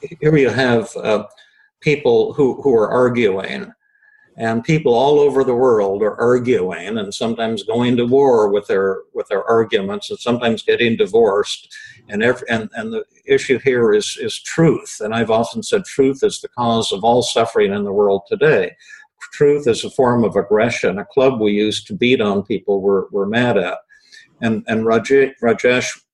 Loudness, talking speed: -17 LUFS, 180 wpm